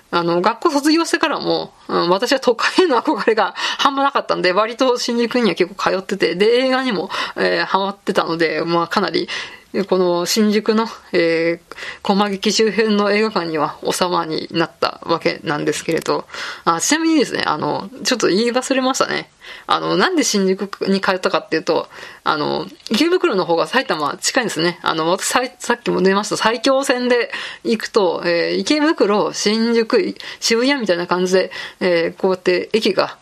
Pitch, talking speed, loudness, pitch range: 210 Hz, 345 characters per minute, -17 LUFS, 175-250 Hz